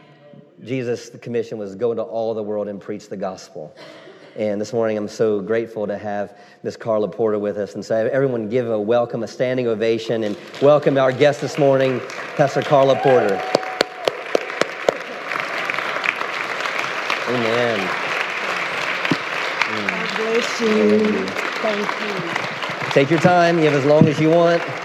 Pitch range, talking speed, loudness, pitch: 110-150 Hz, 145 wpm, -20 LUFS, 125 Hz